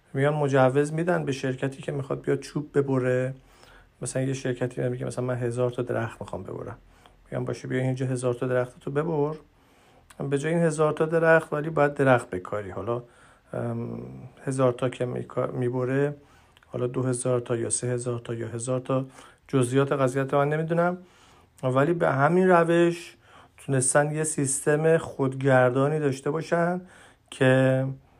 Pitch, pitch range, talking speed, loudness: 130 Hz, 125-145 Hz, 155 wpm, -25 LUFS